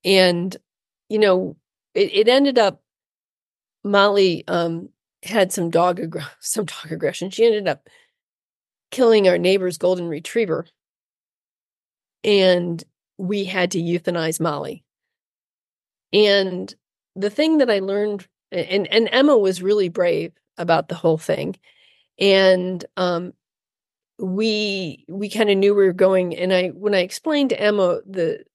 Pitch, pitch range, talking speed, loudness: 190 Hz, 180-210 Hz, 135 wpm, -19 LUFS